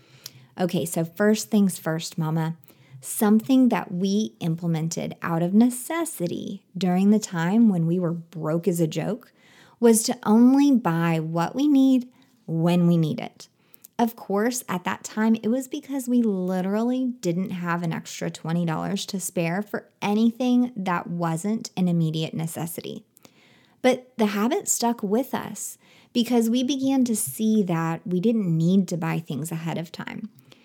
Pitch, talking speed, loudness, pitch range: 195 Hz, 155 wpm, -24 LUFS, 170-235 Hz